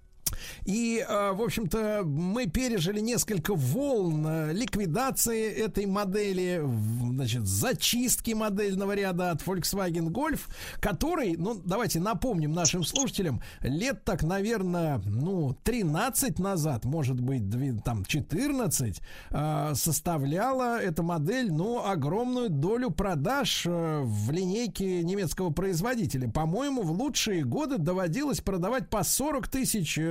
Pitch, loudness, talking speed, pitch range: 185 Hz, -29 LUFS, 110 wpm, 155-220 Hz